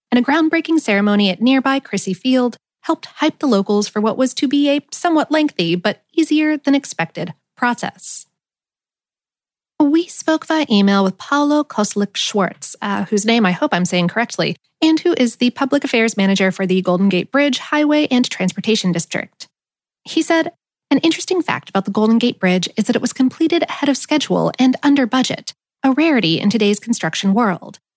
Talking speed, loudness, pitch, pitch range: 180 wpm, -17 LUFS, 245 Hz, 200-295 Hz